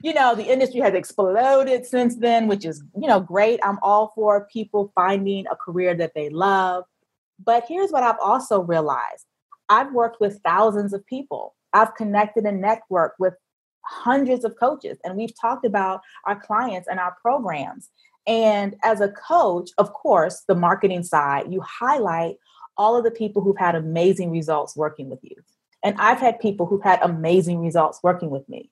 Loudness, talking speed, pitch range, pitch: -21 LUFS, 180 wpm, 180-230 Hz, 205 Hz